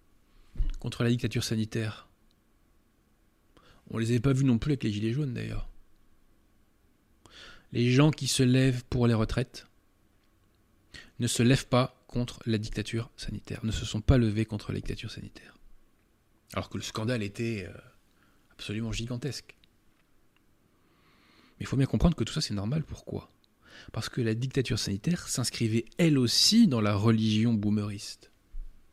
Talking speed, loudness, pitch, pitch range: 150 wpm, -29 LUFS, 115 Hz, 105-125 Hz